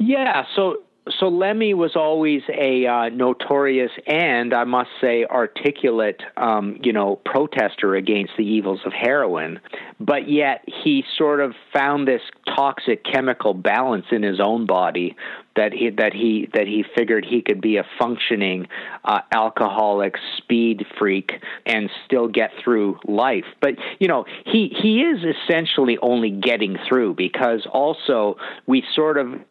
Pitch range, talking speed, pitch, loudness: 105-150 Hz, 150 wpm, 120 Hz, -20 LUFS